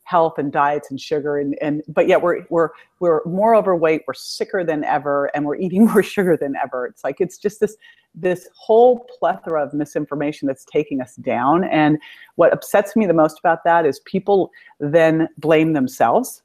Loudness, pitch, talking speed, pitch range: -18 LUFS, 160 Hz, 190 wpm, 150-195 Hz